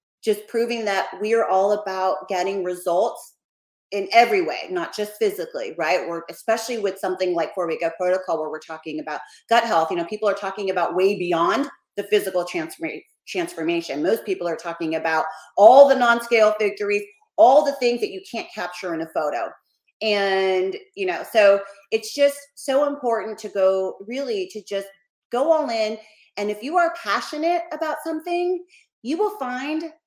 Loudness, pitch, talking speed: -22 LUFS, 220 Hz, 175 wpm